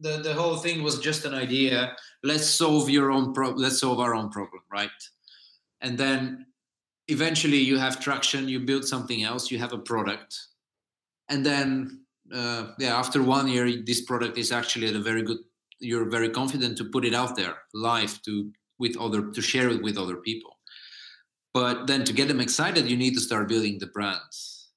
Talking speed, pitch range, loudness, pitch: 190 wpm, 115-135 Hz, -26 LUFS, 125 Hz